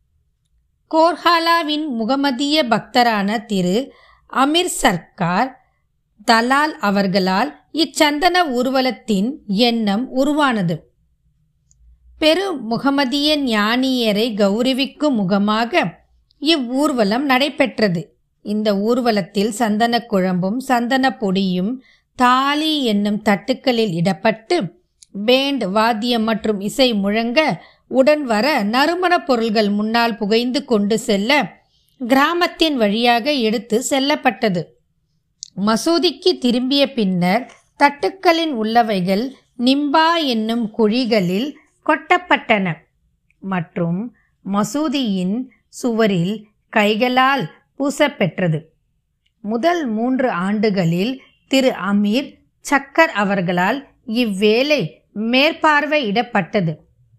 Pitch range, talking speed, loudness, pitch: 205-280 Hz, 70 wpm, -17 LUFS, 235 Hz